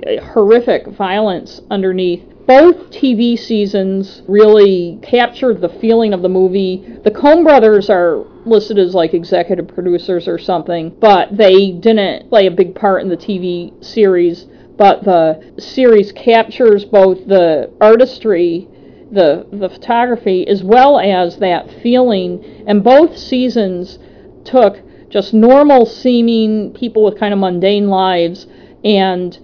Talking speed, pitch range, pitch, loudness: 130 wpm, 185-235 Hz, 205 Hz, -11 LUFS